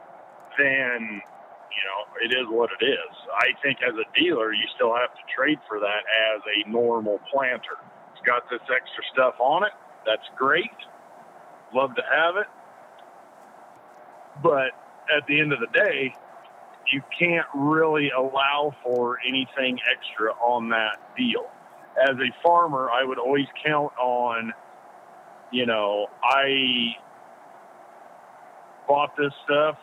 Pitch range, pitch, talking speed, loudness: 120-150 Hz, 135 Hz, 135 wpm, -23 LUFS